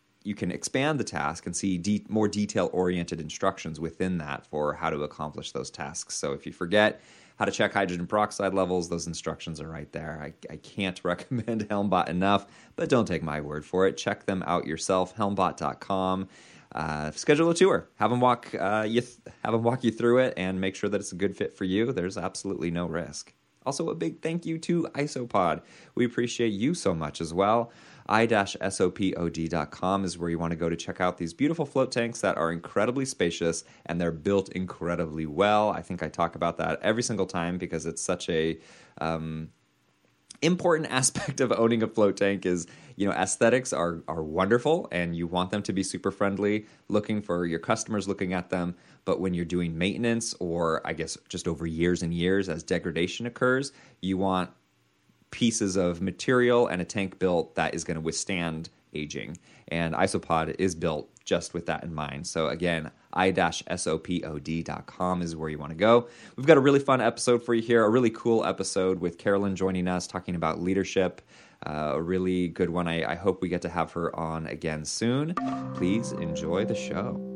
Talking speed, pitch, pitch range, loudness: 195 wpm, 90 Hz, 85-105 Hz, -28 LUFS